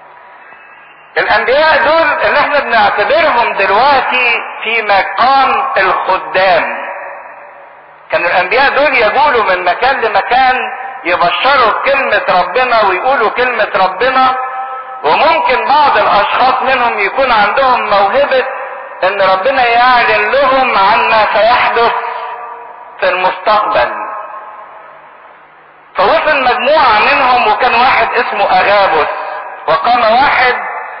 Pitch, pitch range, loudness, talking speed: 240 Hz, 200-260 Hz, -10 LUFS, 90 wpm